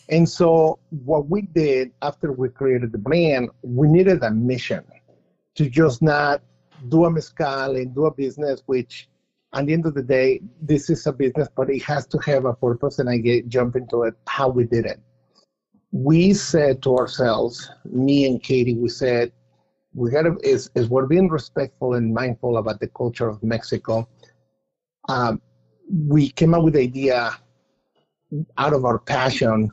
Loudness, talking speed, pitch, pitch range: -20 LUFS, 175 wpm, 135 Hz, 120-155 Hz